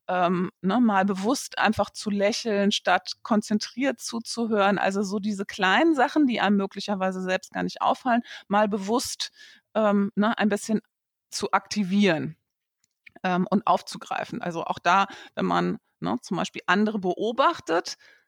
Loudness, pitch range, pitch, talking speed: -25 LUFS, 190-230 Hz, 205 Hz, 140 wpm